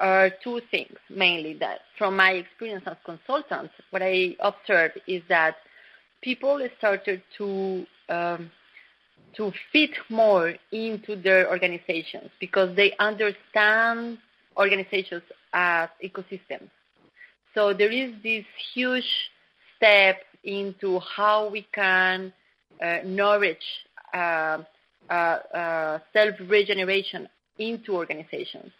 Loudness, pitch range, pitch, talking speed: -24 LUFS, 185-215 Hz, 195 Hz, 105 wpm